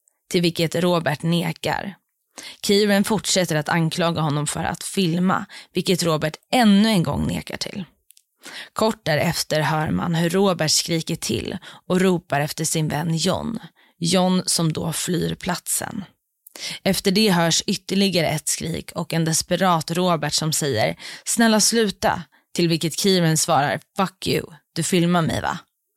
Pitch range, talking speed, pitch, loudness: 160-195 Hz, 145 wpm, 170 Hz, -21 LUFS